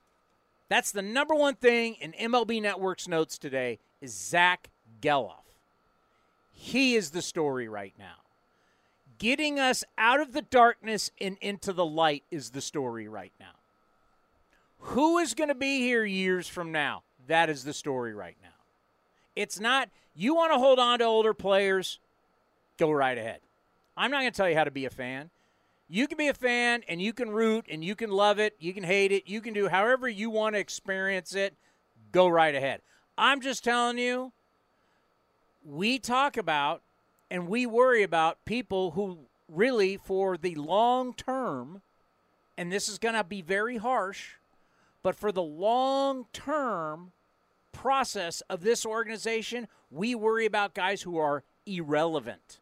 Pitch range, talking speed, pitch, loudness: 140-230 Hz, 165 wpm, 190 Hz, -28 LUFS